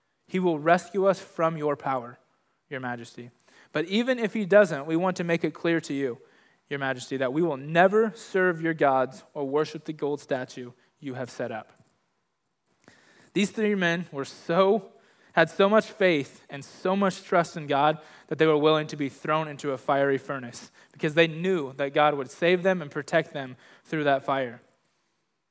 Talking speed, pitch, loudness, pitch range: 190 wpm, 155 Hz, -26 LUFS, 140-185 Hz